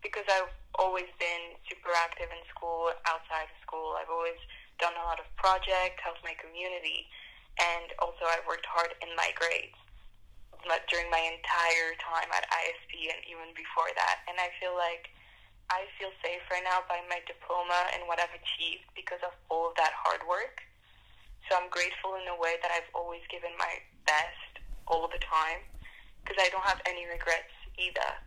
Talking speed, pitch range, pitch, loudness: 180 wpm, 165-180 Hz, 170 Hz, -32 LUFS